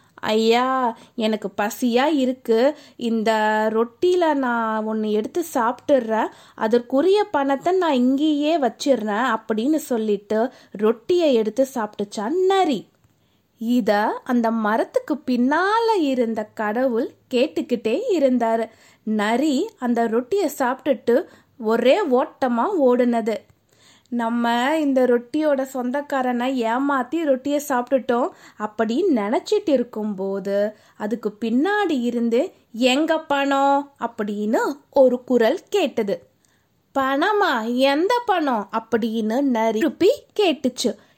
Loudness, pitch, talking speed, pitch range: -21 LUFS, 250 Hz, 90 wpm, 225-290 Hz